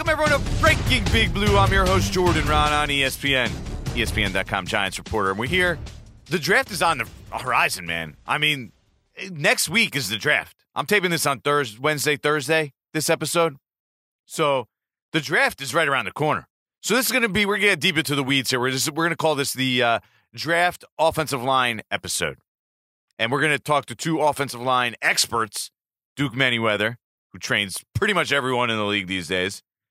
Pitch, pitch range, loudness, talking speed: 140 Hz, 110-160 Hz, -21 LUFS, 200 wpm